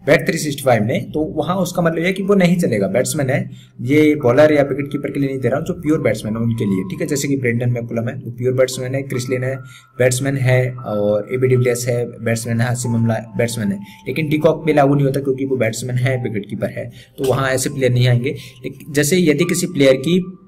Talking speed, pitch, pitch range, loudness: 220 wpm, 130 Hz, 120-150 Hz, -17 LUFS